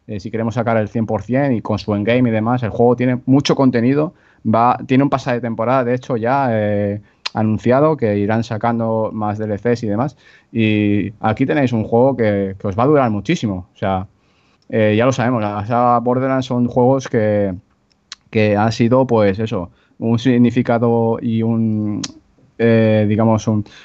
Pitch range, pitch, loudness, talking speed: 105-125 Hz, 115 Hz, -17 LUFS, 175 wpm